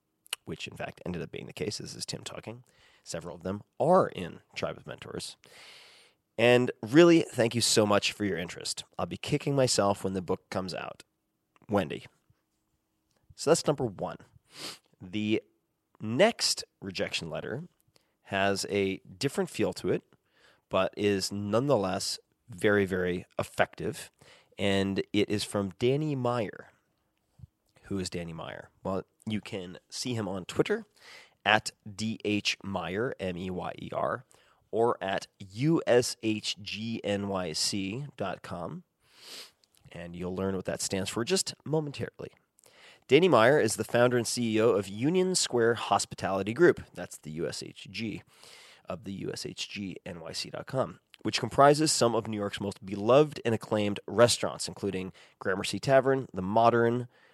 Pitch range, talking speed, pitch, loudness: 95-120 Hz, 135 wpm, 105 Hz, -29 LUFS